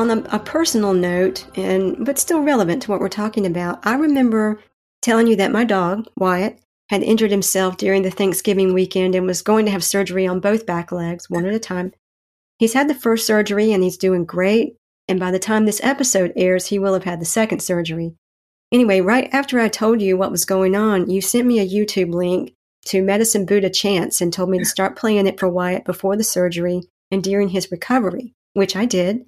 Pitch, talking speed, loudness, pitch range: 195 Hz, 215 wpm, -18 LUFS, 185-220 Hz